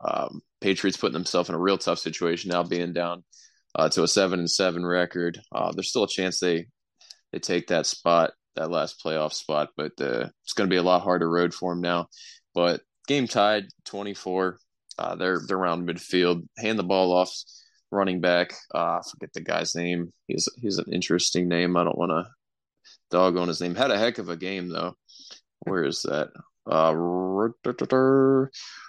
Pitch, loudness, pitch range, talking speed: 90 Hz, -25 LUFS, 85-95 Hz, 190 wpm